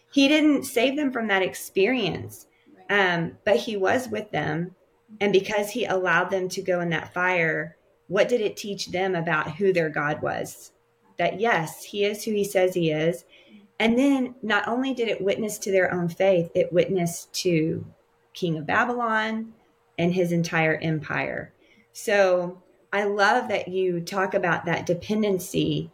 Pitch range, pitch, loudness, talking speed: 175-210 Hz, 190 Hz, -24 LUFS, 165 wpm